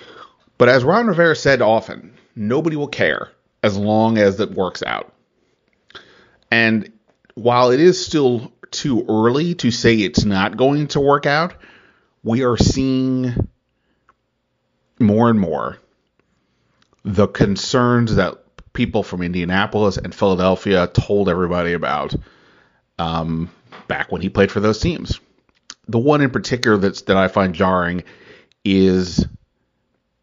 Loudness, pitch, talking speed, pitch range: -17 LUFS, 110 Hz, 130 wpm, 95-130 Hz